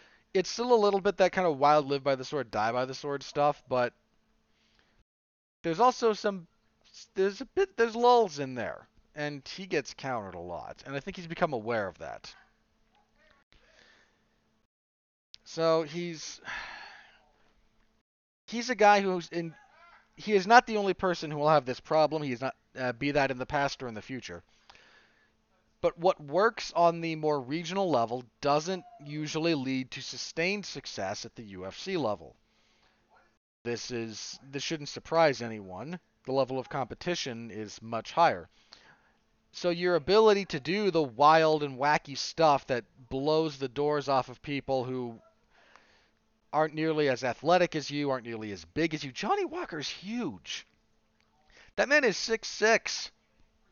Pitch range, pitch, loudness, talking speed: 130-180 Hz, 150 Hz, -29 LUFS, 160 wpm